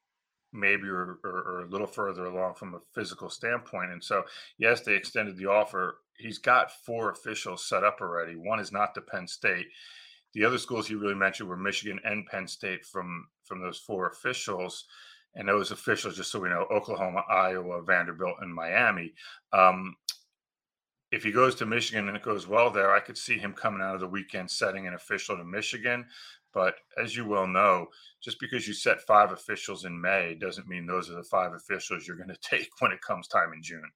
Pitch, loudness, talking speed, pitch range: 95 Hz, -29 LUFS, 205 wpm, 90-110 Hz